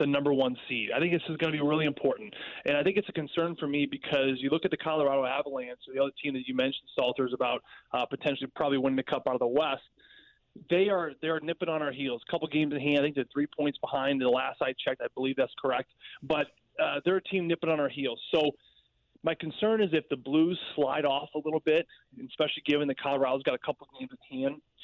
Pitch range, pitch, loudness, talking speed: 135-165 Hz, 145 Hz, -30 LUFS, 255 wpm